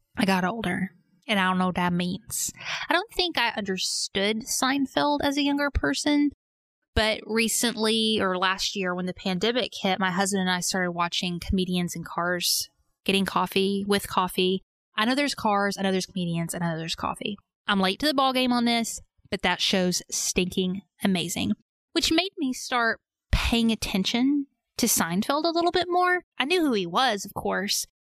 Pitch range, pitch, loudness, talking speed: 185-255 Hz, 205 Hz, -25 LUFS, 185 wpm